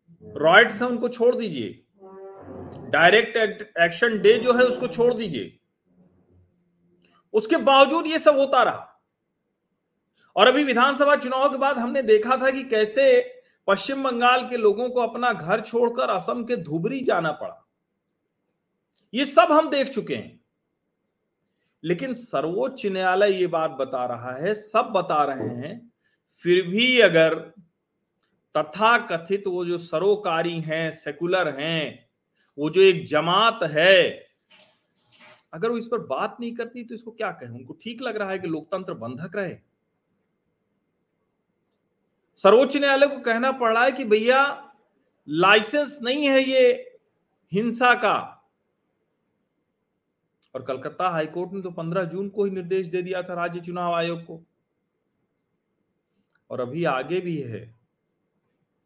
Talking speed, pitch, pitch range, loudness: 135 wpm, 210 Hz, 175-250 Hz, -22 LUFS